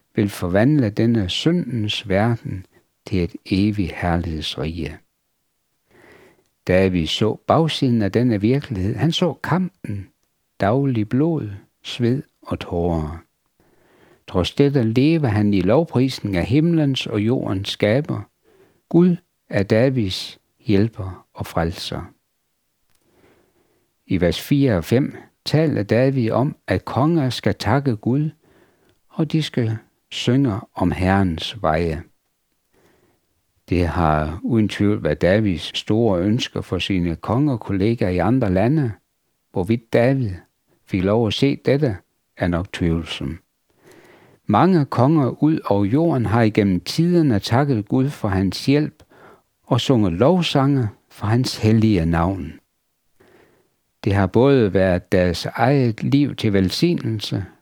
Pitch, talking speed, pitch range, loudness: 110 Hz, 120 wpm, 95-135 Hz, -20 LUFS